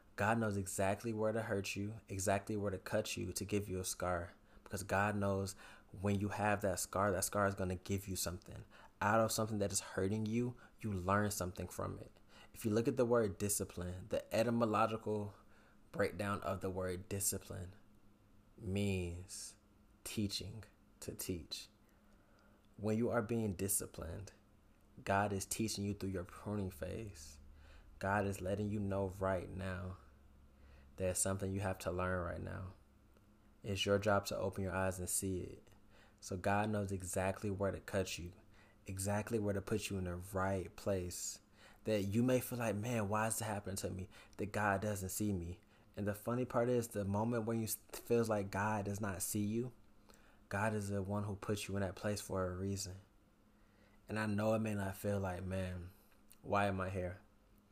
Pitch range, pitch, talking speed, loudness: 95-105 Hz, 100 Hz, 185 wpm, -39 LUFS